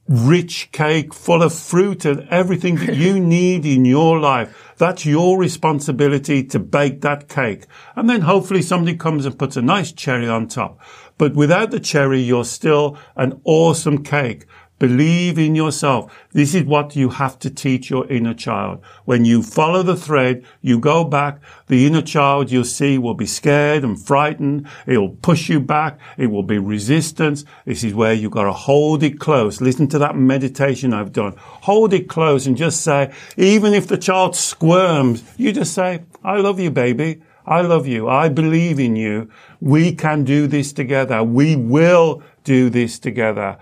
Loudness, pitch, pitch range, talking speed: -16 LUFS, 145 Hz, 130-165 Hz, 180 wpm